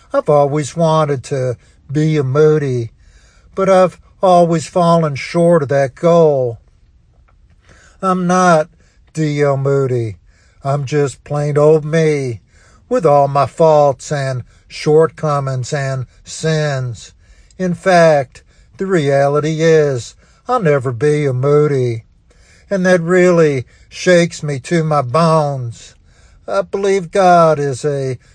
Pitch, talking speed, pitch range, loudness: 145 Hz, 115 wpm, 125-165 Hz, -14 LUFS